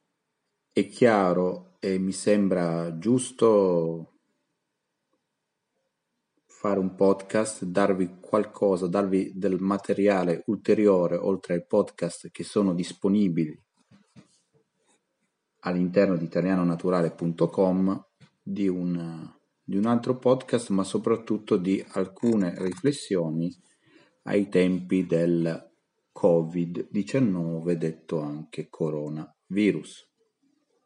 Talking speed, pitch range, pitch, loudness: 80 wpm, 85-100 Hz, 95 Hz, -26 LUFS